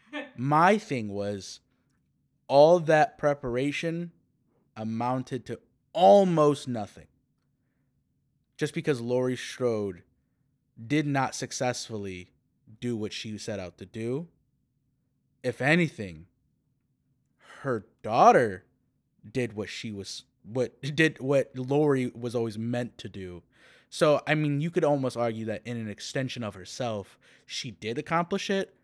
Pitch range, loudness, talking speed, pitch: 110-145 Hz, -27 LUFS, 120 wpm, 125 Hz